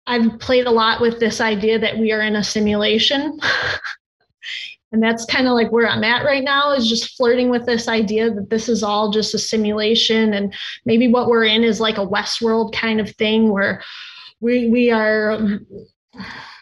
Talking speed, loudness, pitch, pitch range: 190 wpm, -17 LUFS, 225 Hz, 215-240 Hz